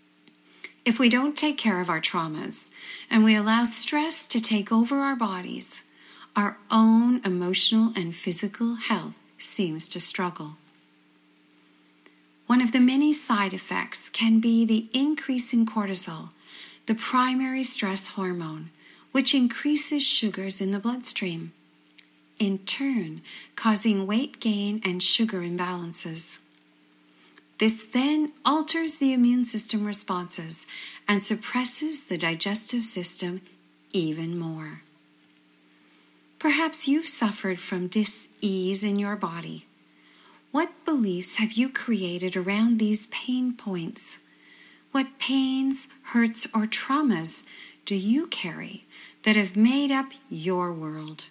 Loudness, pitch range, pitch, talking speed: -23 LUFS, 175-250 Hz, 210 Hz, 120 wpm